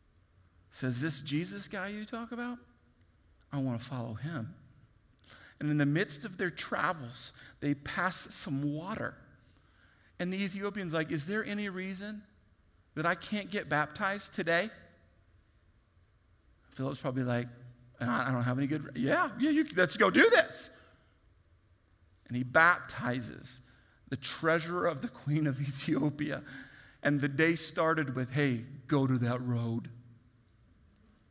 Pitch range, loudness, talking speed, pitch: 110-165 Hz, -32 LUFS, 140 wpm, 135 Hz